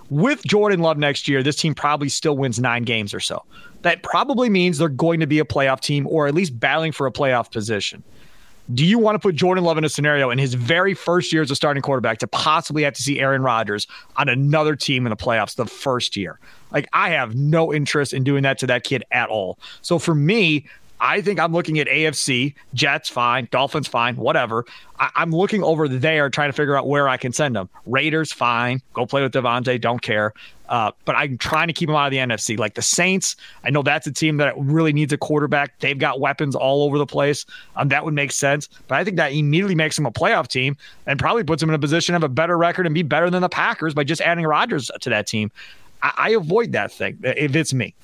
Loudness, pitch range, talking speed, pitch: -19 LUFS, 130-160 Hz, 240 wpm, 145 Hz